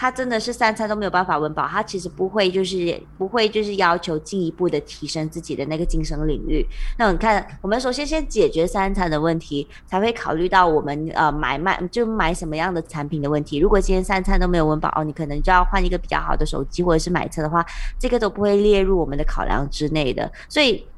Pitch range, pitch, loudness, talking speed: 155-200 Hz, 180 Hz, -21 LUFS, 365 characters per minute